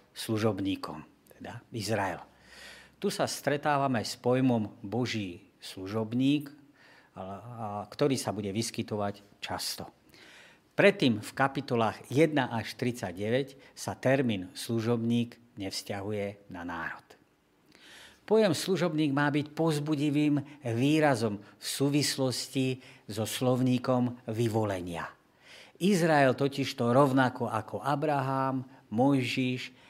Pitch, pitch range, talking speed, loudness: 125 Hz, 110-140 Hz, 90 wpm, -30 LUFS